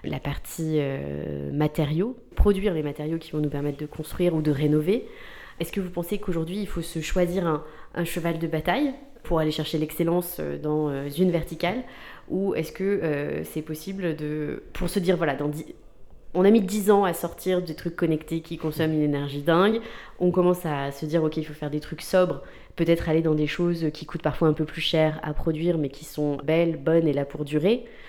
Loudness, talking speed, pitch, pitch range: -26 LUFS, 215 wpm, 160 Hz, 150-180 Hz